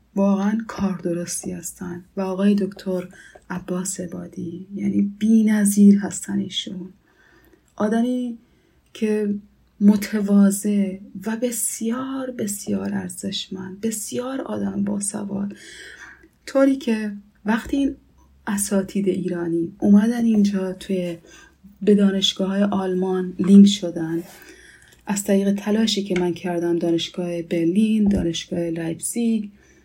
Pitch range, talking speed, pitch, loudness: 185-210 Hz, 100 wpm, 200 Hz, -21 LUFS